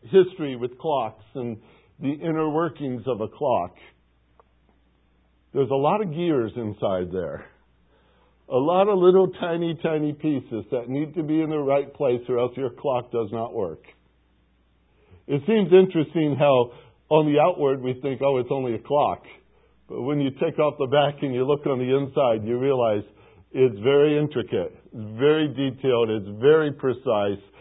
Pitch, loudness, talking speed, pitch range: 135 Hz, -23 LUFS, 165 wpm, 110-150 Hz